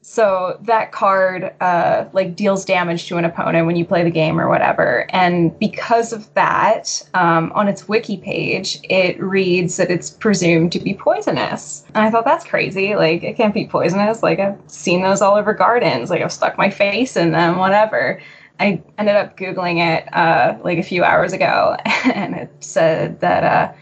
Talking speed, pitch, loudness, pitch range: 190 wpm, 190 Hz, -16 LUFS, 175-210 Hz